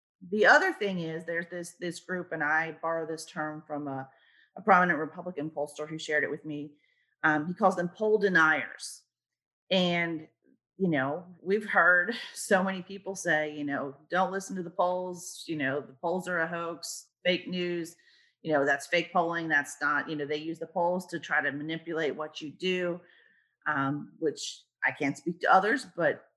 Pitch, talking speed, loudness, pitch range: 170 Hz, 190 wpm, -29 LUFS, 155-180 Hz